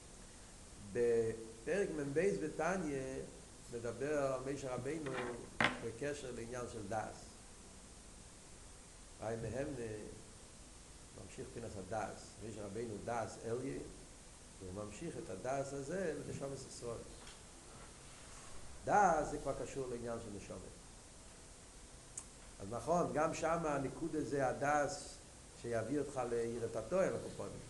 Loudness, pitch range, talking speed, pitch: -41 LUFS, 105-140 Hz, 95 wpm, 115 Hz